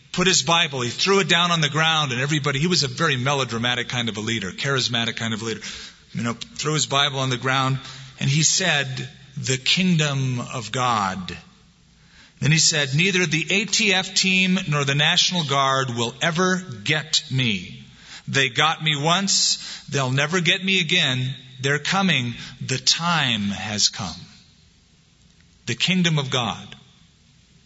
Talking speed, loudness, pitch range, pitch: 165 wpm, -20 LUFS, 125-170 Hz, 140 Hz